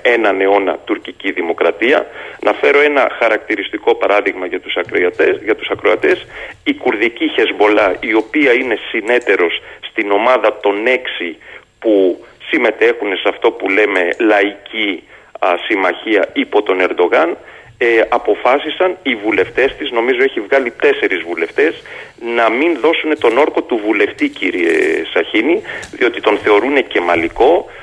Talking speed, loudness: 130 wpm, -14 LUFS